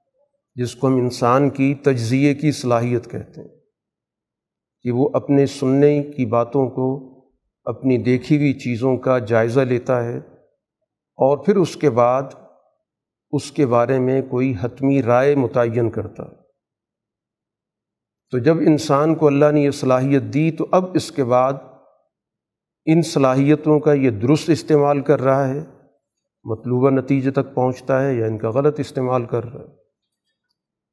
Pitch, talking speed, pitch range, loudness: 135 Hz, 145 wpm, 125-145 Hz, -18 LUFS